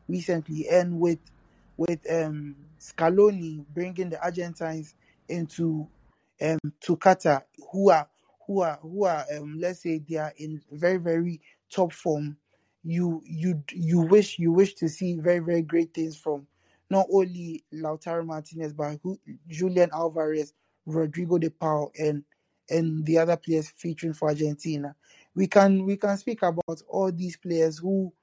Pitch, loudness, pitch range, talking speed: 165 Hz, -26 LUFS, 155-180 Hz, 150 wpm